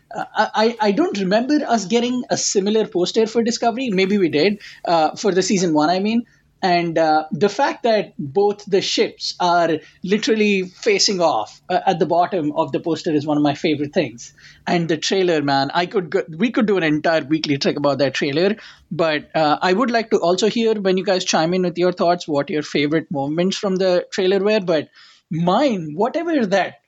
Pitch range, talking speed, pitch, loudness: 165-215 Hz, 205 wpm, 185 Hz, -19 LUFS